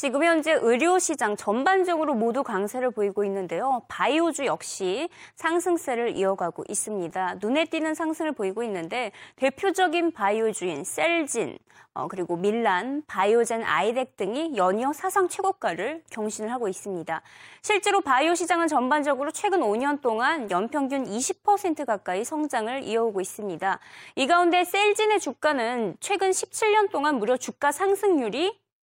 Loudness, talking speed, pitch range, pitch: -25 LUFS, 330 characters per minute, 215-345 Hz, 275 Hz